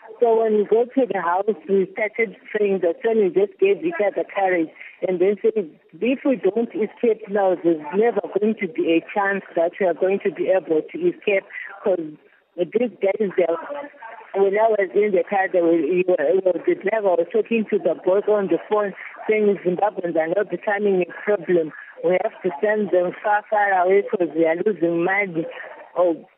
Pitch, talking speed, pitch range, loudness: 195 Hz, 200 wpm, 180-215 Hz, -21 LUFS